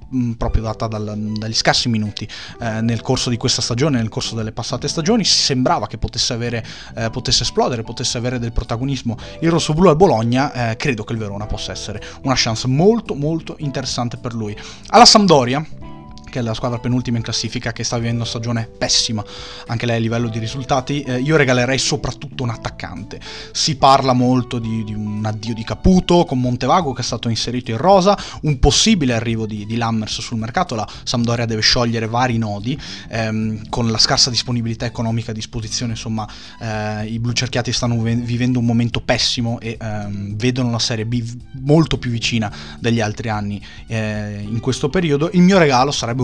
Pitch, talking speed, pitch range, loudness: 120 Hz, 185 wpm, 110-130 Hz, -18 LUFS